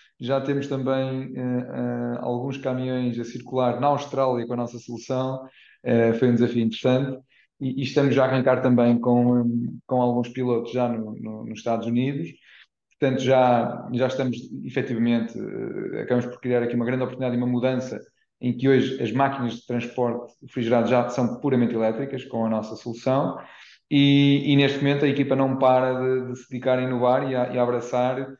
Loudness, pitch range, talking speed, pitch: -23 LUFS, 120-130 Hz, 185 wpm, 125 Hz